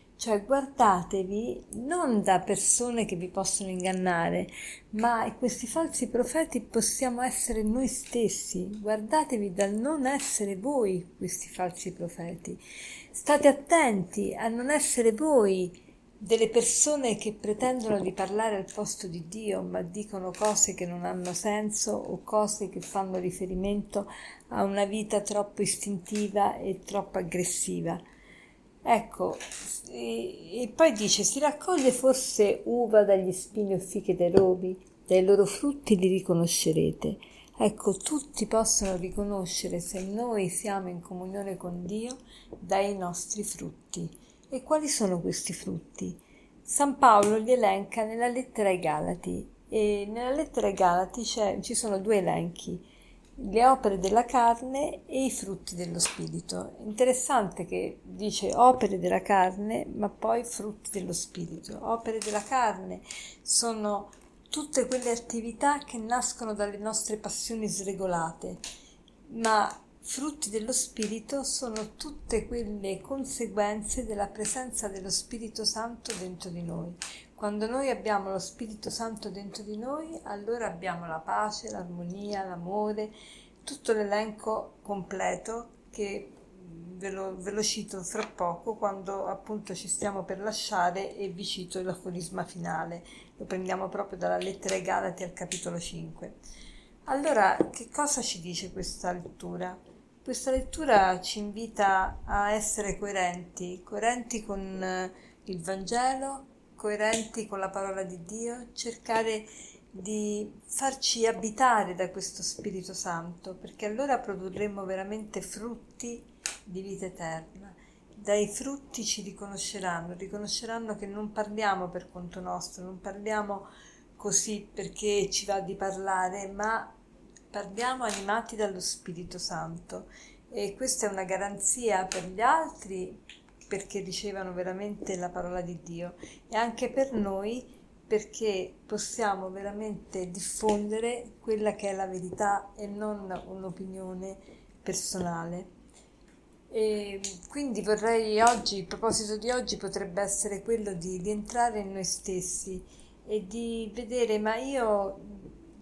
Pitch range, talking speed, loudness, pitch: 190-230 Hz, 125 wpm, -29 LUFS, 205 Hz